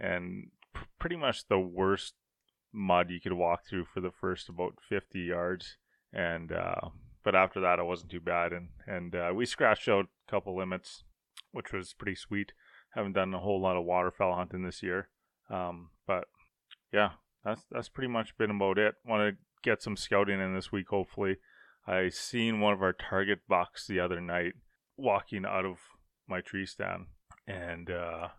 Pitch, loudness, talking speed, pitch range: 95 Hz, -33 LUFS, 180 wpm, 90-100 Hz